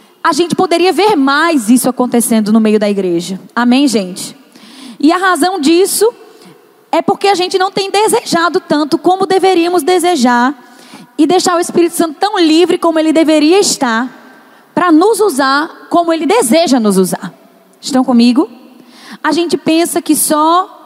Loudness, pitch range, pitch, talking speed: -11 LUFS, 255-360 Hz, 320 Hz, 155 wpm